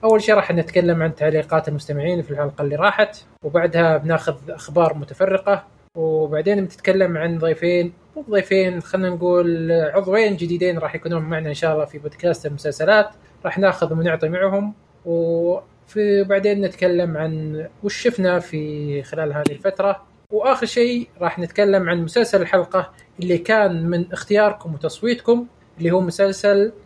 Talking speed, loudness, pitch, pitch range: 140 wpm, -20 LUFS, 175 Hz, 160-200 Hz